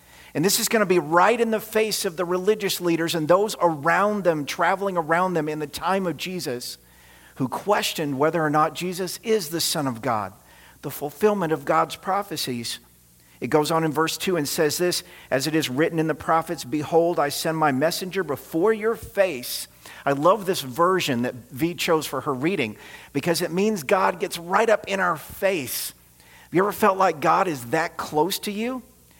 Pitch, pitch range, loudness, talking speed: 165 Hz, 145-190 Hz, -23 LUFS, 200 wpm